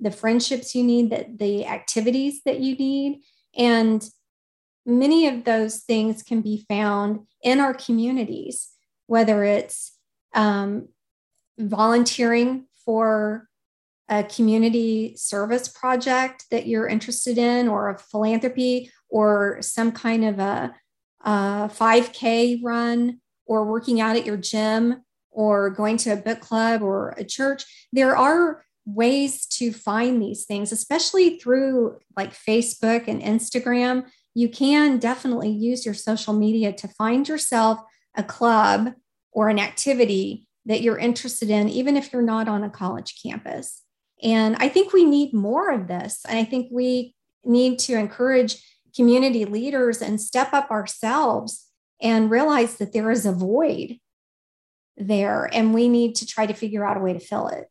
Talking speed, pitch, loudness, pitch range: 150 wpm, 230 Hz, -22 LUFS, 215-250 Hz